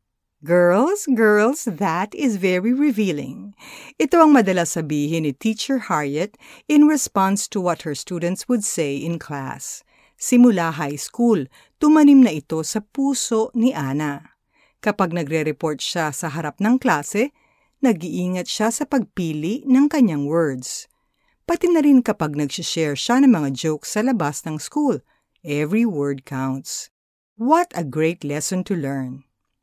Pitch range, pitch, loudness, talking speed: 155-245 Hz, 185 Hz, -20 LUFS, 140 wpm